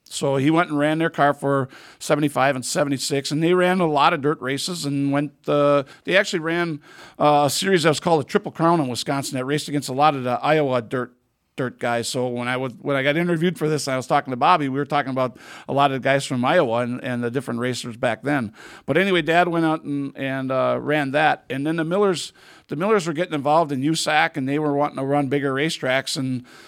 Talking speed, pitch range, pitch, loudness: 245 wpm, 135-160 Hz, 145 Hz, -21 LUFS